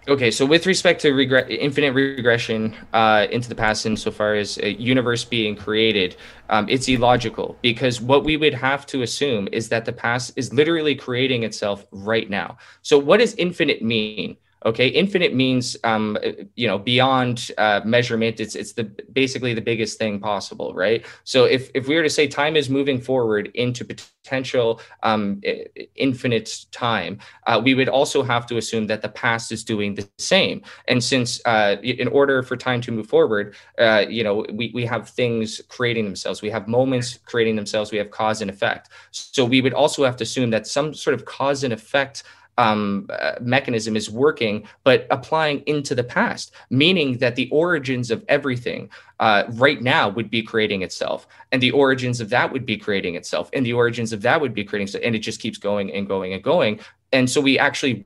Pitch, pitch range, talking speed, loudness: 120 Hz, 110-135 Hz, 195 wpm, -20 LUFS